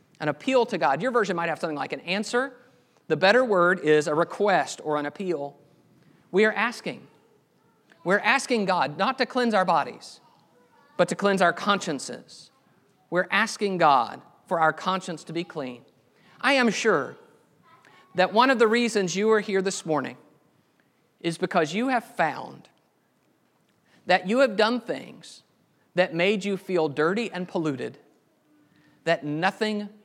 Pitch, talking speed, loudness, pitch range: 190 Hz, 155 wpm, -24 LUFS, 165-220 Hz